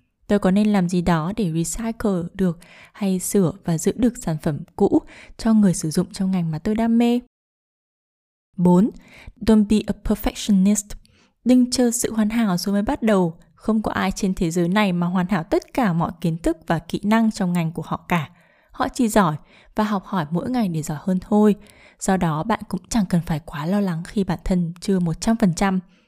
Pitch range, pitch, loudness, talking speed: 175-215 Hz, 195 Hz, -21 LUFS, 210 wpm